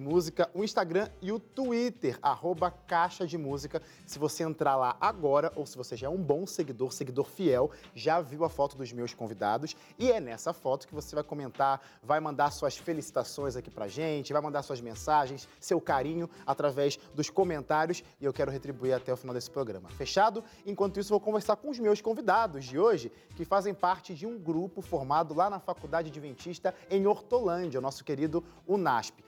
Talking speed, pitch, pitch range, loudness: 190 wpm, 160 Hz, 140-185 Hz, -31 LUFS